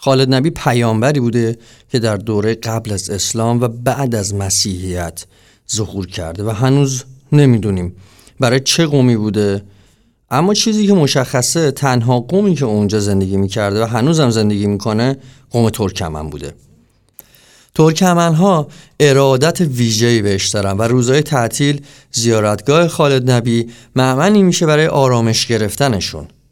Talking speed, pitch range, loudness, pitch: 130 wpm, 105-140 Hz, -14 LUFS, 120 Hz